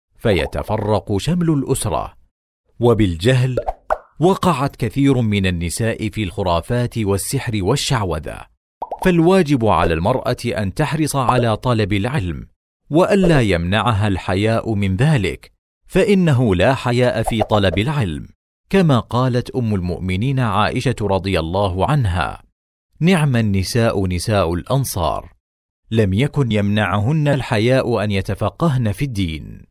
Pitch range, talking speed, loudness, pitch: 100-135 Hz, 105 wpm, -18 LUFS, 115 Hz